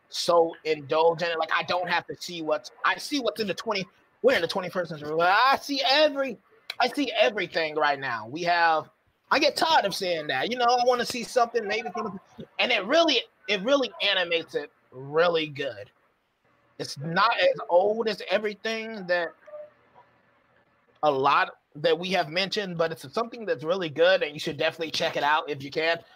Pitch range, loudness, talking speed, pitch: 165-245 Hz, -25 LUFS, 185 wpm, 190 Hz